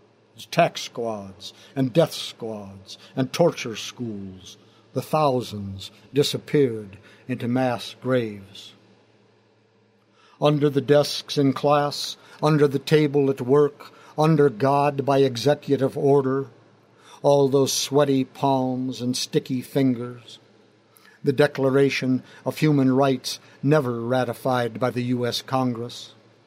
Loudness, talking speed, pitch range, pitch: -22 LUFS, 105 wpm, 110-140 Hz, 130 Hz